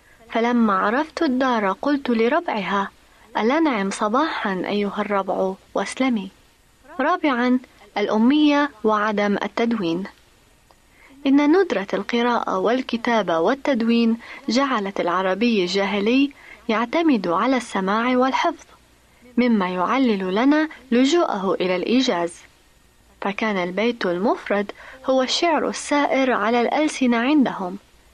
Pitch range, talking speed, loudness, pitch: 205-275 Hz, 85 wpm, -21 LUFS, 235 Hz